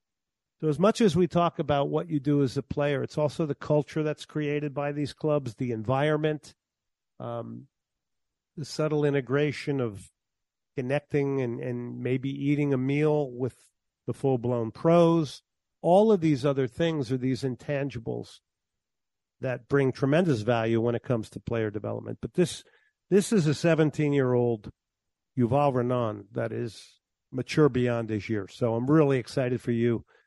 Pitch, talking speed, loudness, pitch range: 140 Hz, 160 wpm, -27 LUFS, 120-150 Hz